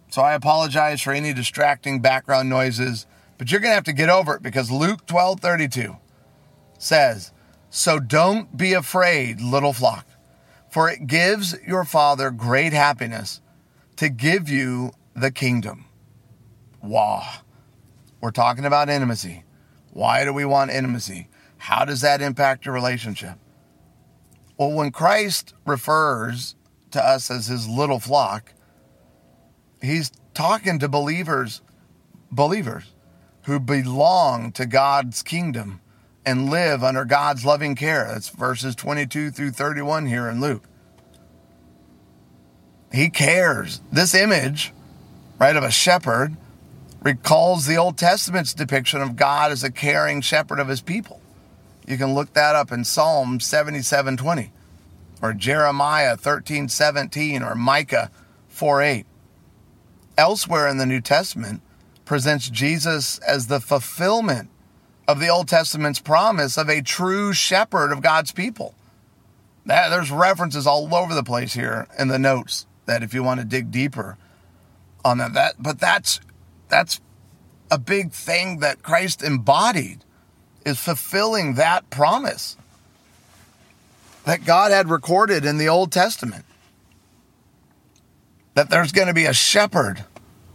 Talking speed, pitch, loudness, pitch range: 130 wpm, 140 Hz, -20 LUFS, 120-155 Hz